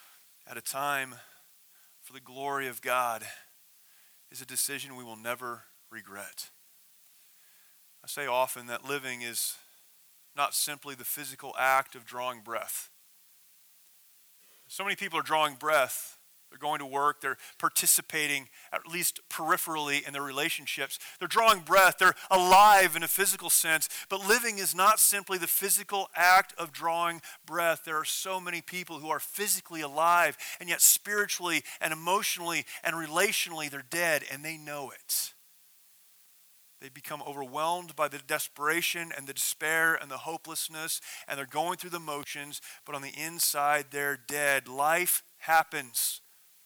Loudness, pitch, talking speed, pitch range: -28 LUFS, 150 Hz, 150 wpm, 135-170 Hz